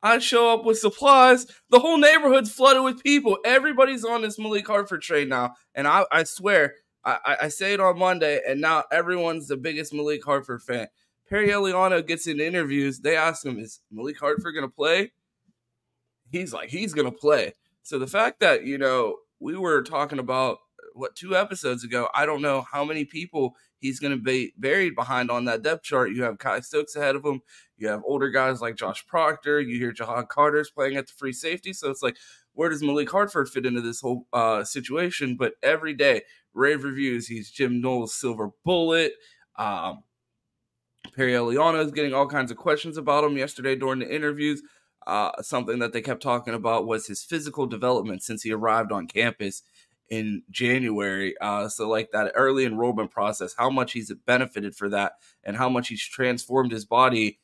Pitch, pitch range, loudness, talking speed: 135 Hz, 120-165 Hz, -24 LUFS, 195 wpm